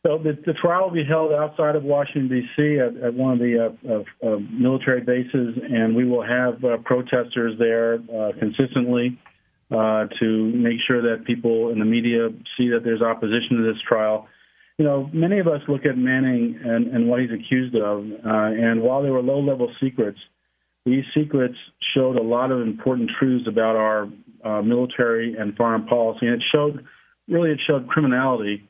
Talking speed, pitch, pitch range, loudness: 185 wpm, 120 Hz, 115-135 Hz, -21 LUFS